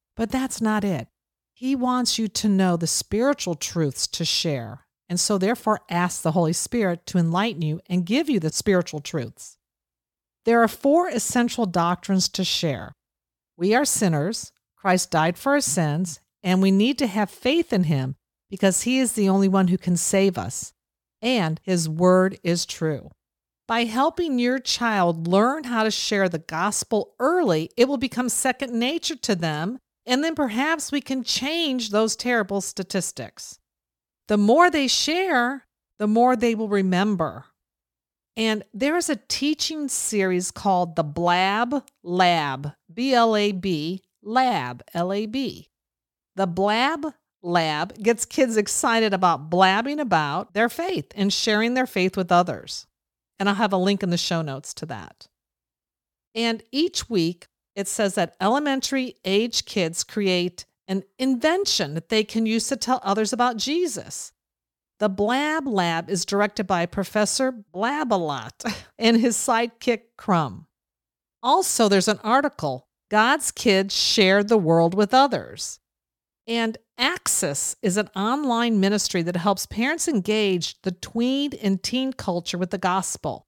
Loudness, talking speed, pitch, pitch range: -22 LUFS, 150 wpm, 200 Hz, 175-240 Hz